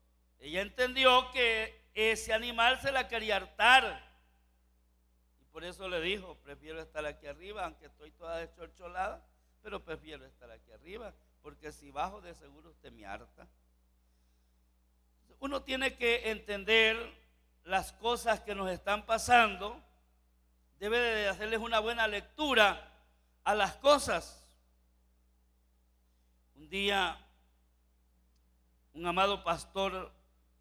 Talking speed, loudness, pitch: 115 wpm, -31 LUFS, 160 Hz